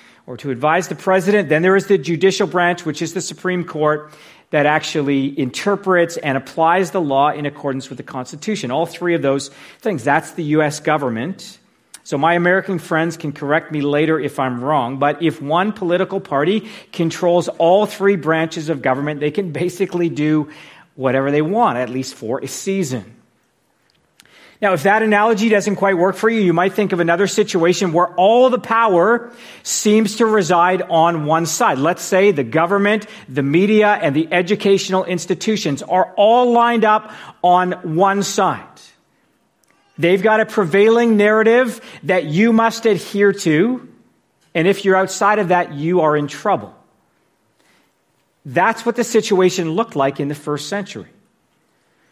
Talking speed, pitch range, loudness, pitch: 165 wpm, 150-205 Hz, -16 LUFS, 175 Hz